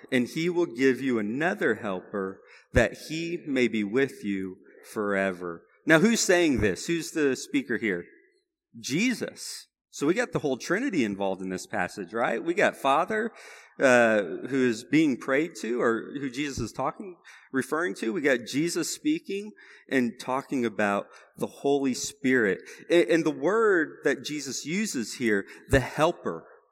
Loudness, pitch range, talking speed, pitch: -27 LUFS, 120-185 Hz, 155 wpm, 140 Hz